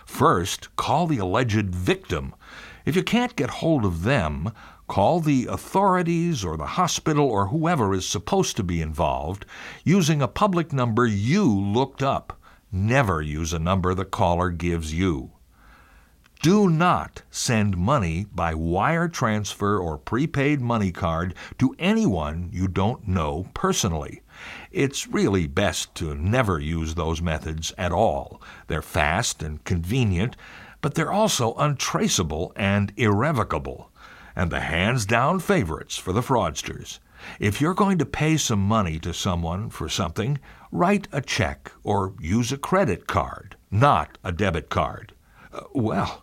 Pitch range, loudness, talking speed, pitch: 90-145 Hz, -24 LUFS, 140 wpm, 105 Hz